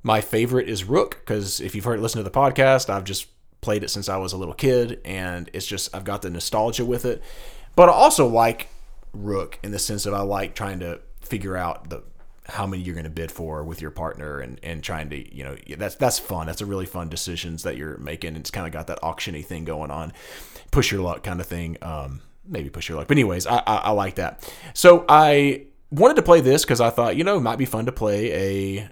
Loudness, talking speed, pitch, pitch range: -21 LUFS, 245 wpm, 95 Hz, 85-115 Hz